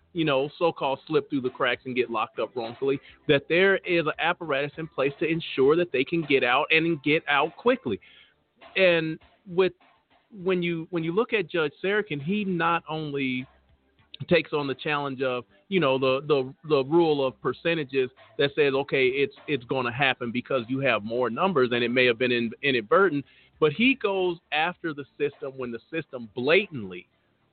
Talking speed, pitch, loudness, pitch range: 185 wpm, 145 Hz, -25 LUFS, 130-170 Hz